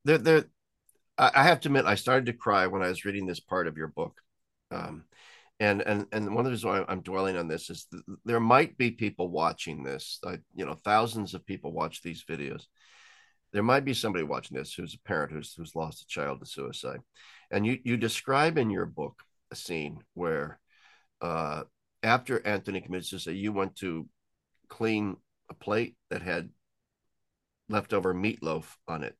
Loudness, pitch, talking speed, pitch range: -29 LUFS, 105 Hz, 185 wpm, 95-120 Hz